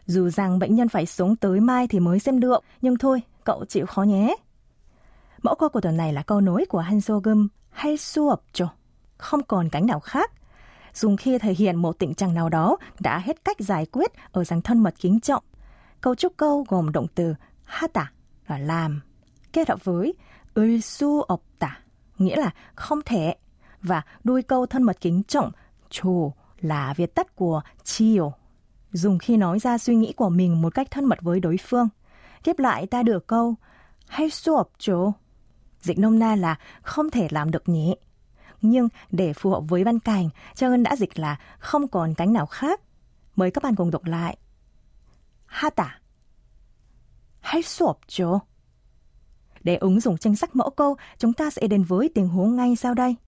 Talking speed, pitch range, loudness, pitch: 185 wpm, 175-250 Hz, -23 LUFS, 200 Hz